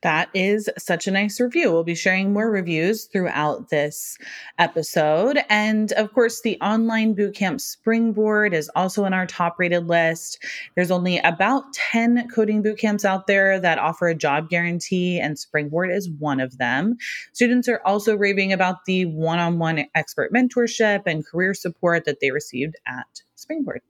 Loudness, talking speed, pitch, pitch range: -21 LUFS, 165 wpm, 185 Hz, 170-215 Hz